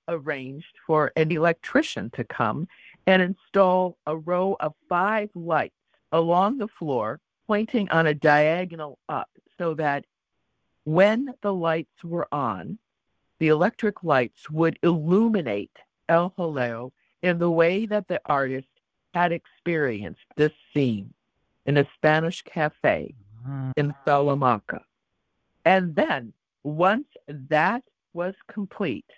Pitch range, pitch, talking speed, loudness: 150-185 Hz, 165 Hz, 115 wpm, -24 LUFS